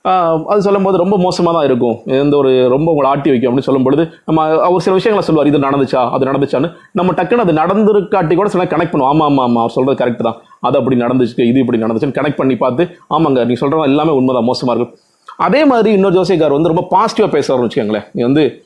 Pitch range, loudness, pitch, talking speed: 130-180 Hz, -13 LUFS, 145 Hz, 210 wpm